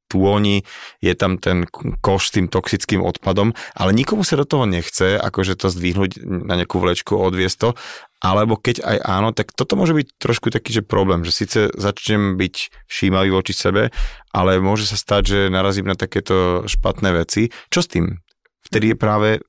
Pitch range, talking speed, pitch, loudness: 95-110 Hz, 175 wpm, 100 Hz, -18 LUFS